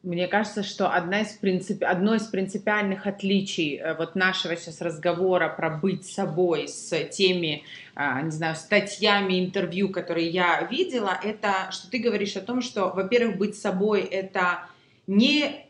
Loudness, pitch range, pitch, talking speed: -25 LUFS, 175-205 Hz, 190 Hz, 145 wpm